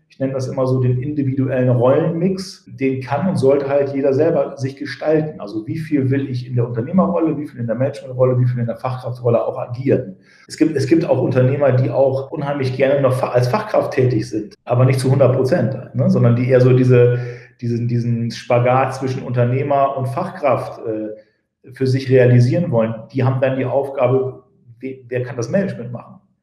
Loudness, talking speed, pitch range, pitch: -17 LUFS, 195 wpm, 125-140 Hz, 130 Hz